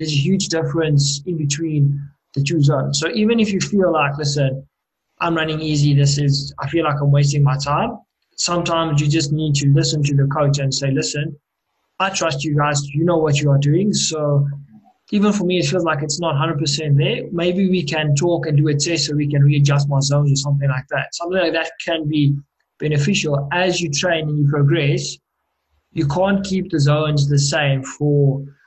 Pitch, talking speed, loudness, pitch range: 150 Hz, 205 wpm, -18 LUFS, 140-165 Hz